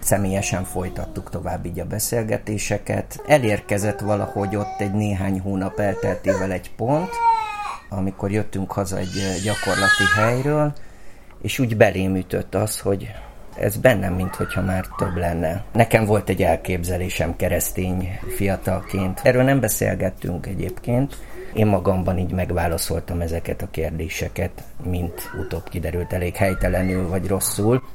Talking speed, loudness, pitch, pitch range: 120 wpm, -22 LUFS, 95 Hz, 90-105 Hz